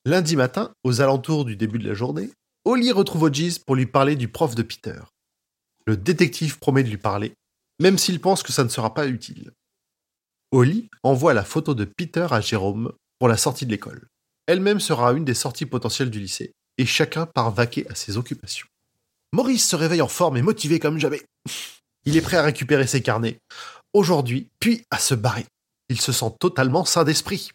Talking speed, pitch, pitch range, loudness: 195 wpm, 135 Hz, 120-165 Hz, -21 LUFS